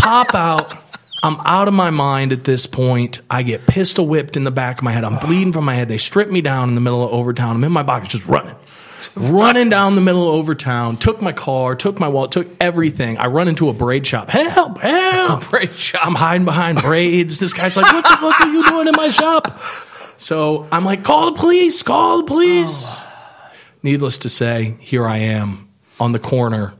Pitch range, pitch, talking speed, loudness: 125-195 Hz, 155 Hz, 215 wpm, -15 LUFS